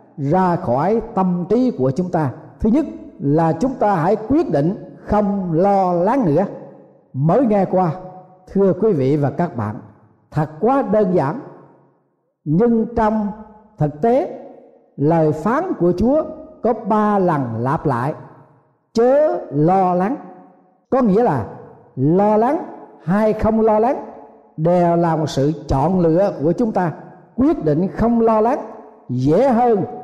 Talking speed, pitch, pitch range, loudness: 145 wpm, 185 Hz, 155-225 Hz, -18 LUFS